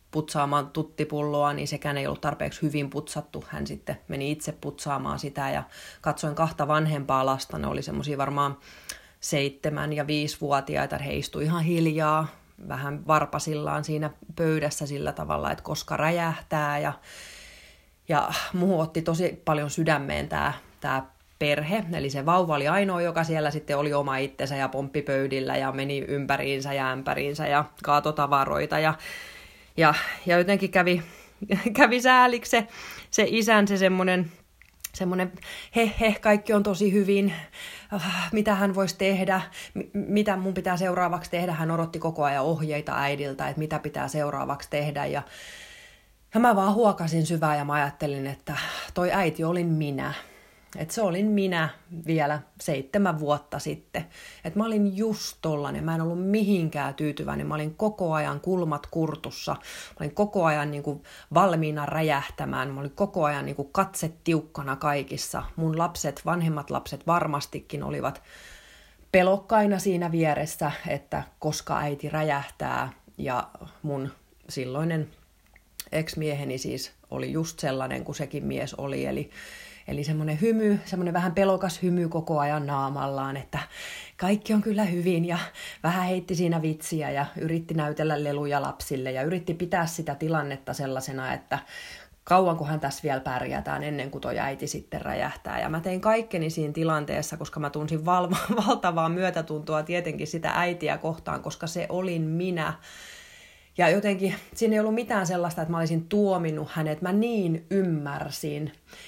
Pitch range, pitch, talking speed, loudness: 145-185 Hz, 160 Hz, 145 wpm, -27 LUFS